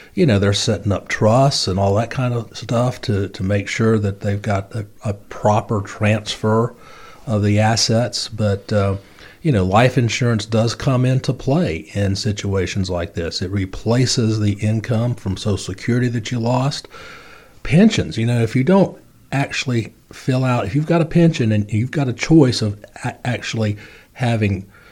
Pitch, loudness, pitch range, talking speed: 110 Hz, -18 LUFS, 100-125 Hz, 175 wpm